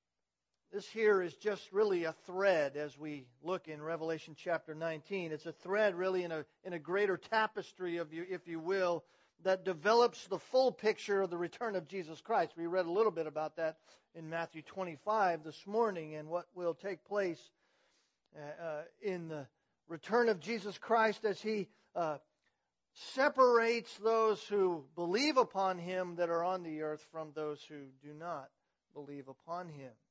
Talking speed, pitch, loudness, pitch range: 165 wpm, 175 Hz, -36 LUFS, 160-205 Hz